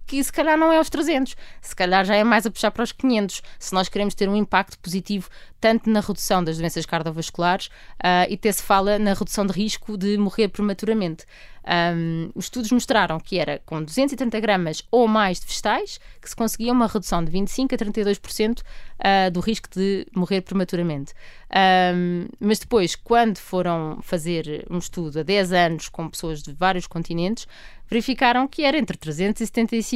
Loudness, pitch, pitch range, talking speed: -22 LUFS, 200 Hz, 175-225 Hz, 180 wpm